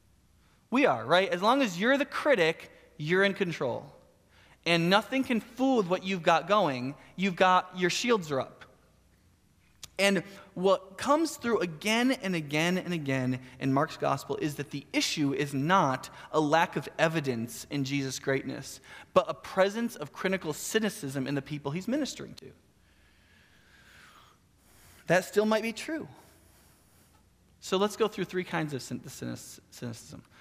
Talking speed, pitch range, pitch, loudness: 150 wpm, 135-195 Hz, 170 Hz, -29 LUFS